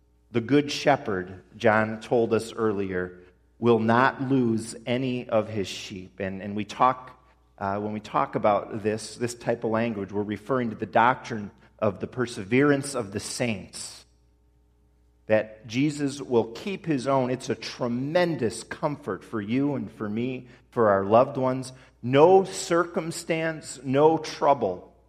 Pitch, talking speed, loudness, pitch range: 115 Hz, 150 wpm, -26 LUFS, 105-135 Hz